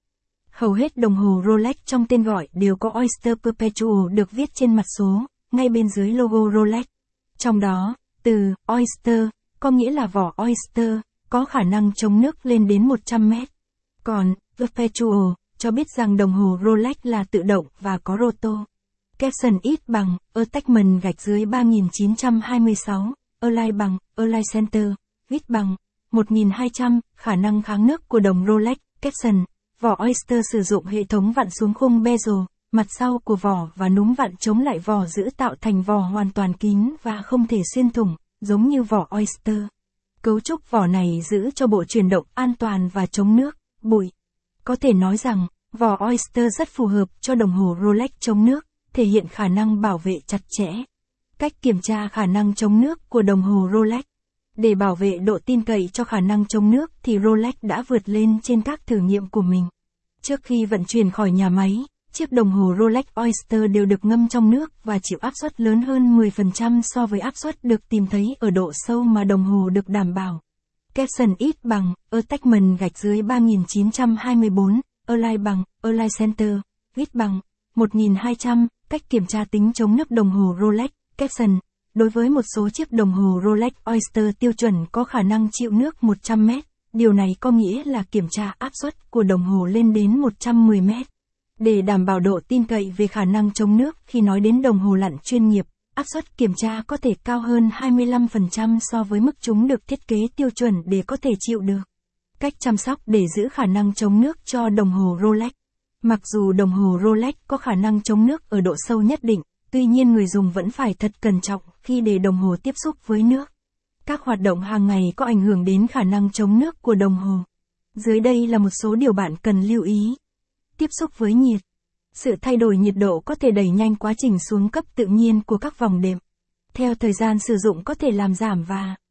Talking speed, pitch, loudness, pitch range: 200 wpm, 220 Hz, -20 LUFS, 200-240 Hz